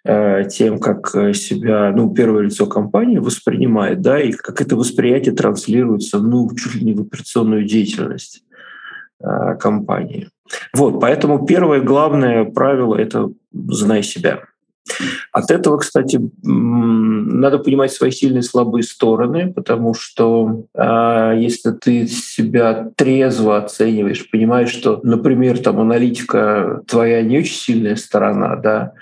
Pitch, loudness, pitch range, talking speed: 115 Hz, -15 LUFS, 110-125 Hz, 120 wpm